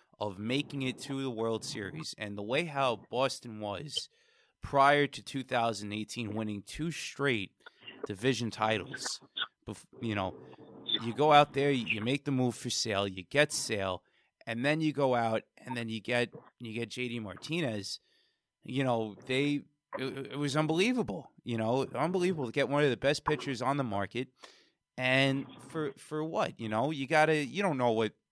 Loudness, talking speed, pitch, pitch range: -32 LUFS, 175 wpm, 130 Hz, 110-145 Hz